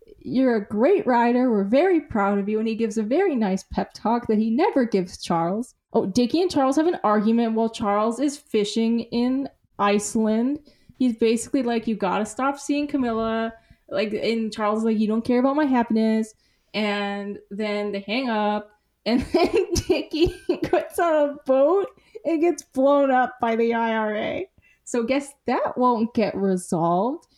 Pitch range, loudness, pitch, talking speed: 215-280 Hz, -23 LUFS, 230 Hz, 175 wpm